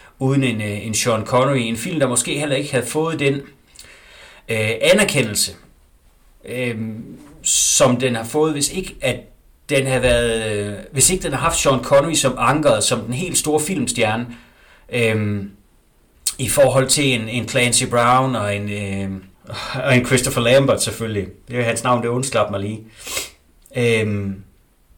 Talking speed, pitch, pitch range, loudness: 160 wpm, 120 Hz, 110-135 Hz, -18 LUFS